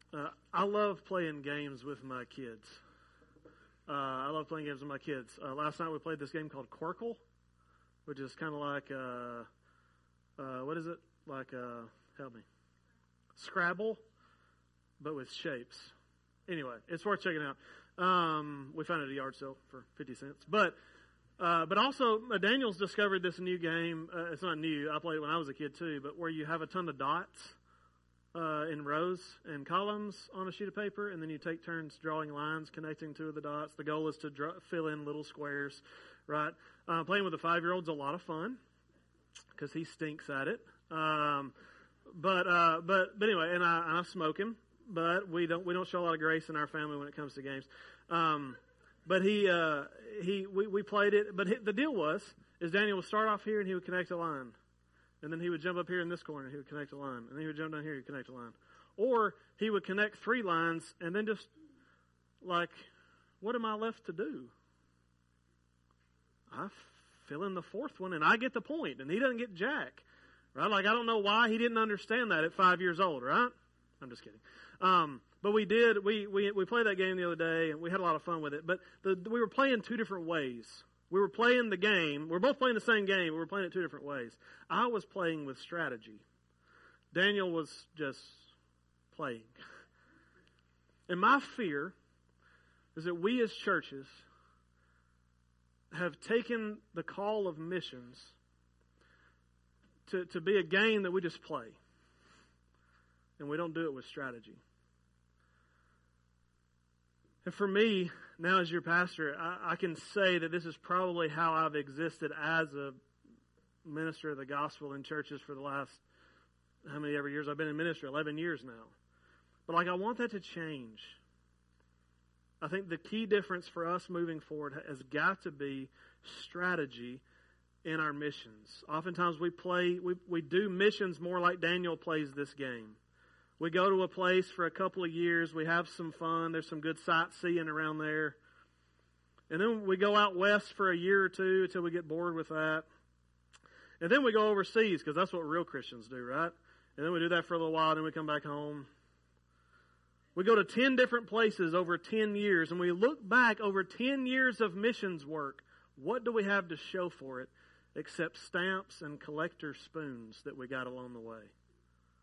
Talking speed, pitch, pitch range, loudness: 195 wpm, 160 Hz, 130-185 Hz, -34 LUFS